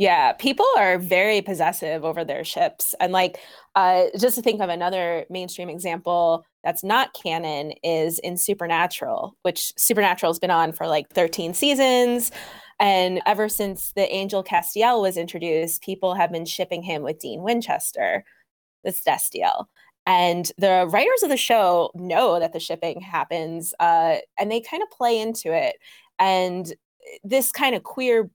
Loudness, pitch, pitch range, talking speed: -22 LUFS, 185 Hz, 170-225 Hz, 155 wpm